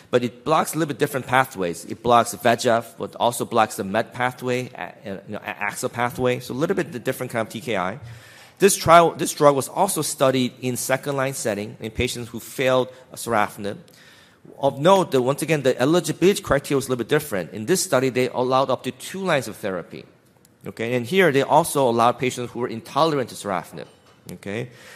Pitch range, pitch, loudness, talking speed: 115-140 Hz, 125 Hz, -22 LUFS, 200 wpm